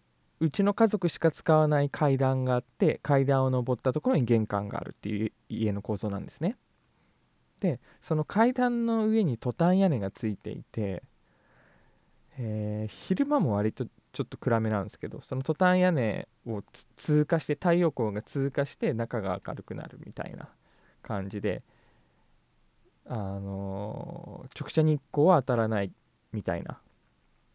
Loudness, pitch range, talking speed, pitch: -29 LUFS, 110-160 Hz, 290 characters per minute, 130 Hz